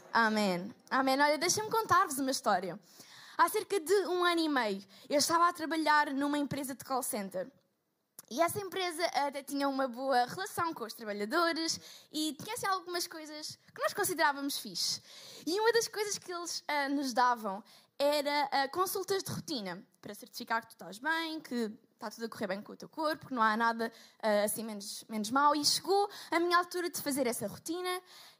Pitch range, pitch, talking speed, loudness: 230-345 Hz, 285 Hz, 190 wpm, -32 LUFS